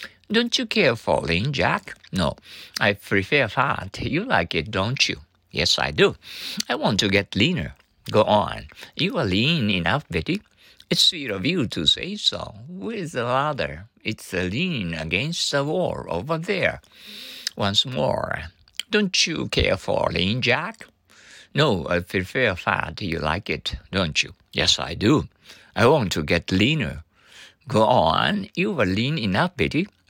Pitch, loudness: 105 Hz, -22 LUFS